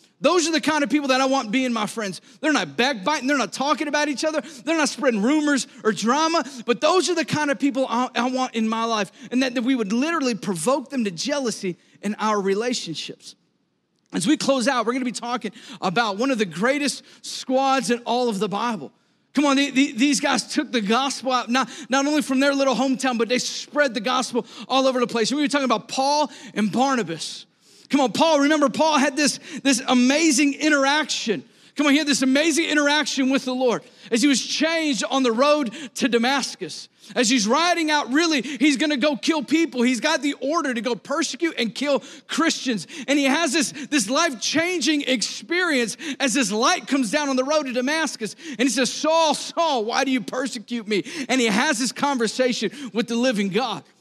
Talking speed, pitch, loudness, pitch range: 215 wpm, 265 Hz, -21 LUFS, 240-295 Hz